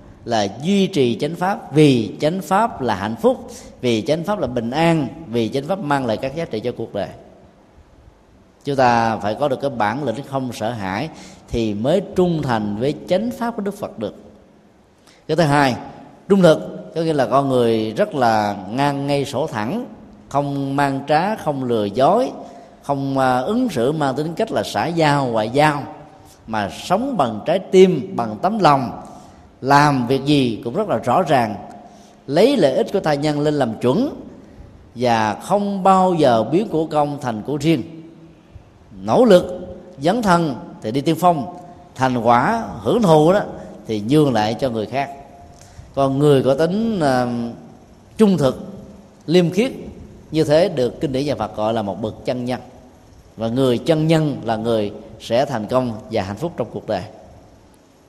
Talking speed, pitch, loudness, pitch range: 180 wpm, 140 Hz, -19 LUFS, 115-165 Hz